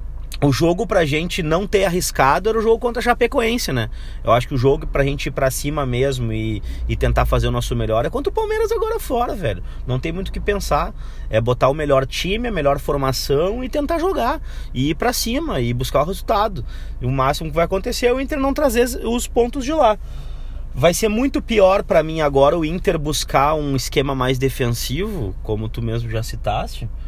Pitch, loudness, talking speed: 150 Hz, -19 LUFS, 220 wpm